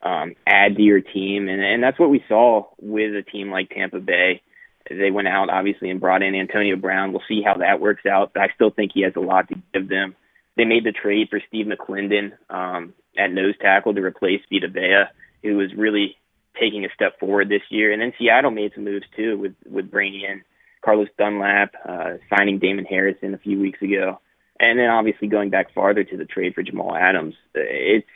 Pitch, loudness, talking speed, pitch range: 100 Hz, -20 LUFS, 215 wpm, 95-105 Hz